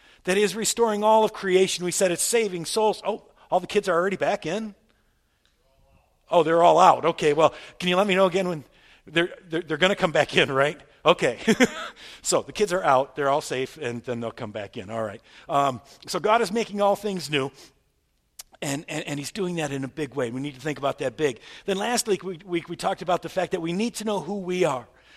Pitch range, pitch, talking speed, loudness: 145-200 Hz, 175 Hz, 240 wpm, -24 LUFS